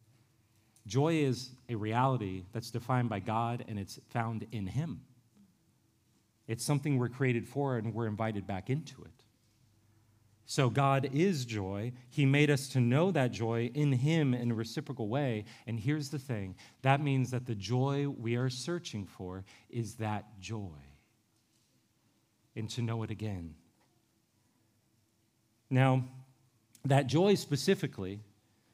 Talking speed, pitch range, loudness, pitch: 140 wpm, 110-135 Hz, -33 LUFS, 120 Hz